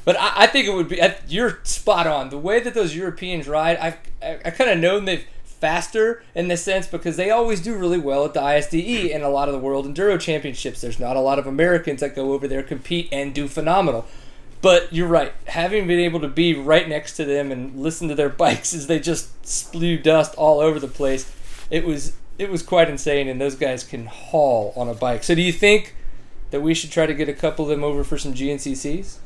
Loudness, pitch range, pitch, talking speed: -20 LUFS, 140-170 Hz, 155 Hz, 240 wpm